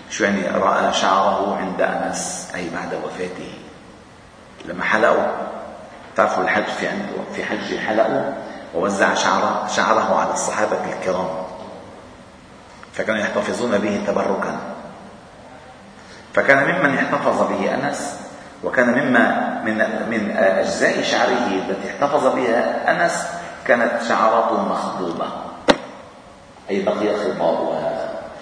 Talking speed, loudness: 105 wpm, -20 LUFS